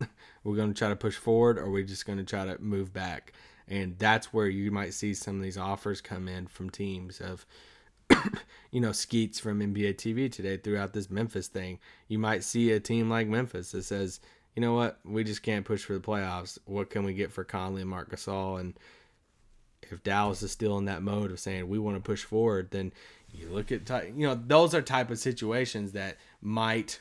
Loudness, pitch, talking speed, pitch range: -31 LUFS, 100 Hz, 220 wpm, 95-110 Hz